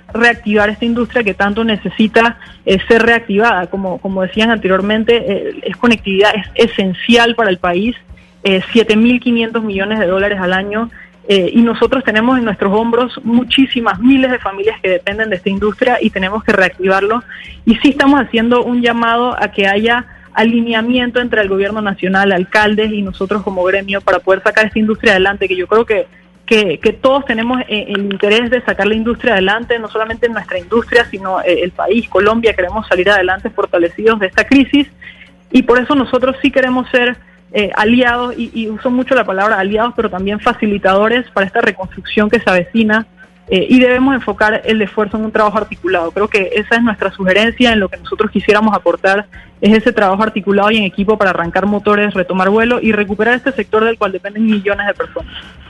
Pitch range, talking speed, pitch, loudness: 195-235 Hz, 185 wpm, 215 Hz, -13 LUFS